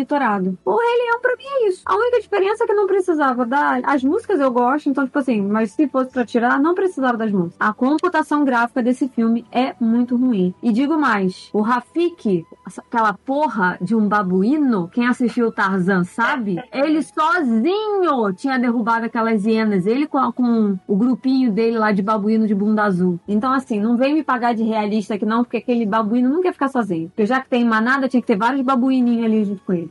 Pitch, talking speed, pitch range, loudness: 245 Hz, 210 wpm, 220-280 Hz, -18 LUFS